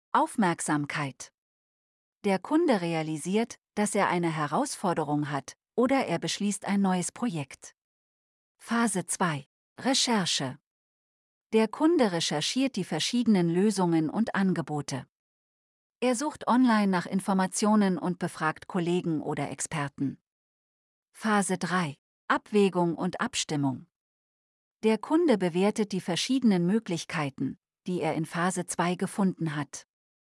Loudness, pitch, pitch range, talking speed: -28 LUFS, 185 Hz, 160-215 Hz, 105 wpm